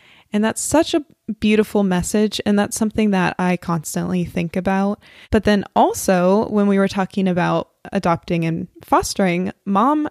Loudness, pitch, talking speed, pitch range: -19 LUFS, 195 Hz, 155 wpm, 180-215 Hz